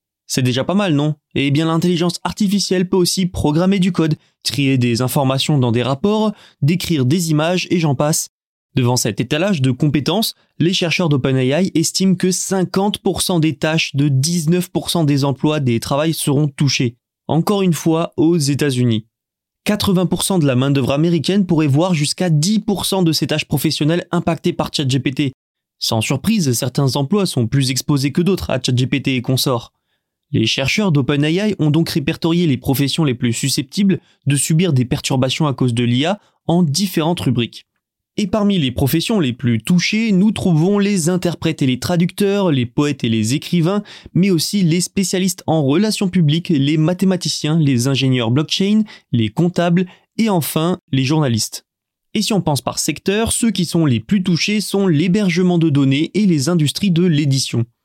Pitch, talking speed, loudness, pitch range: 160 Hz, 170 wpm, -17 LUFS, 140-180 Hz